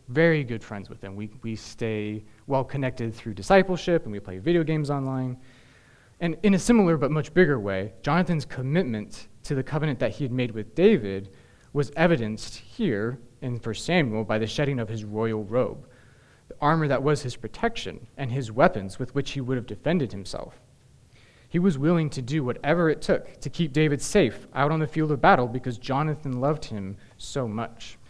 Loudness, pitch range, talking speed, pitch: -26 LUFS, 110-150 Hz, 190 wpm, 130 Hz